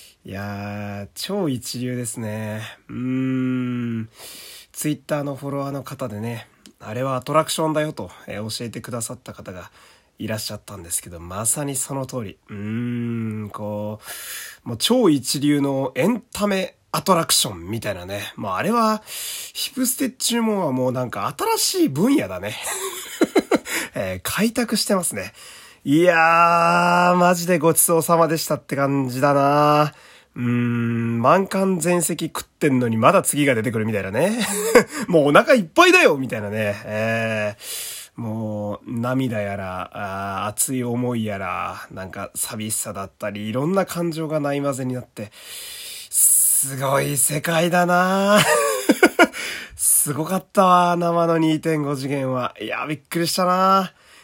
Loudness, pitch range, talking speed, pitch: -20 LUFS, 110-175 Hz, 285 characters per minute, 135 Hz